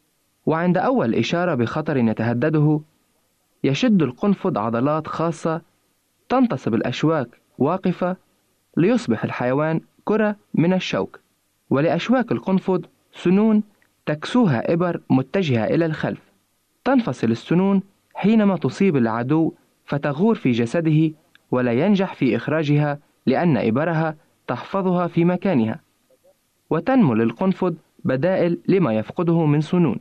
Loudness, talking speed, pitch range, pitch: -21 LUFS, 100 wpm, 145-190 Hz, 170 Hz